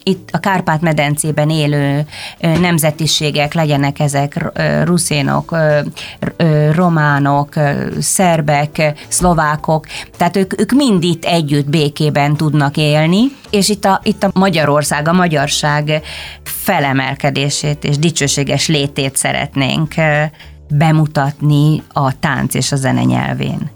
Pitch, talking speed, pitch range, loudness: 150 Hz, 105 wpm, 145-165 Hz, -14 LUFS